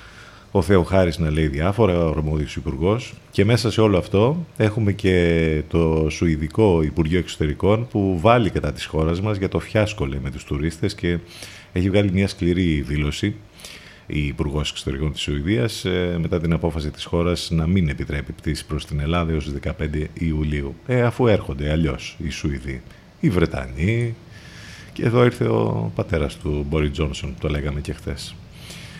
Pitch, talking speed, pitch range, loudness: 85 Hz, 165 wpm, 75-100 Hz, -21 LUFS